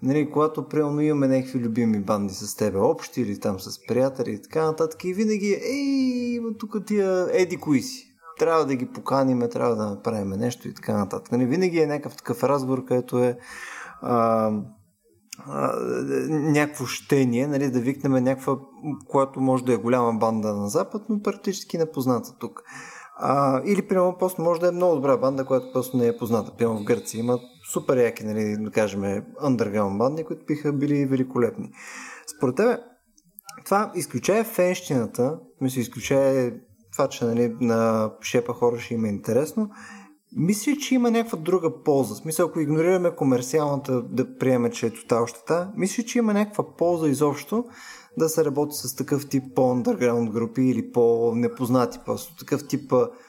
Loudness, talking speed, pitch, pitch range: -24 LUFS, 160 wpm, 135 Hz, 120-175 Hz